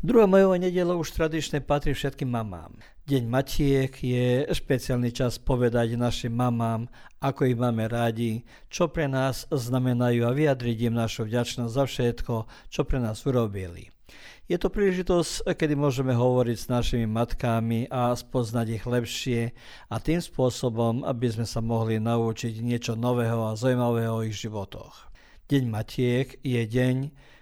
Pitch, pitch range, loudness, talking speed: 125 Hz, 115-135 Hz, -26 LUFS, 145 wpm